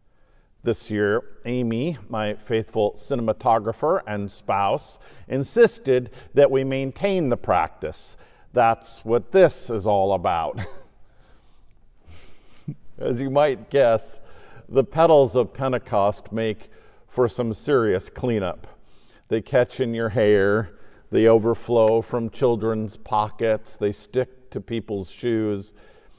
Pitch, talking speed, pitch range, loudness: 115 Hz, 110 wpm, 105-130 Hz, -22 LUFS